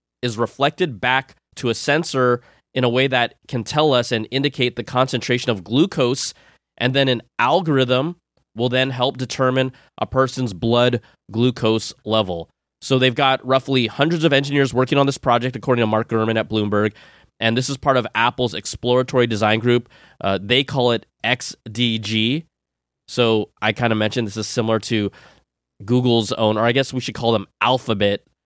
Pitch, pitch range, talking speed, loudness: 125 Hz, 110-130 Hz, 175 wpm, -19 LUFS